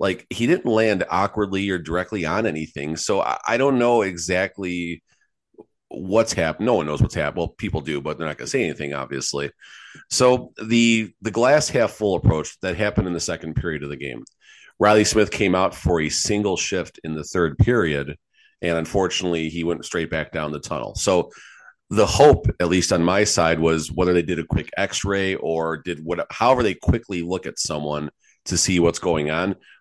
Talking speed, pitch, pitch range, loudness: 195 wpm, 90 Hz, 80-100 Hz, -21 LUFS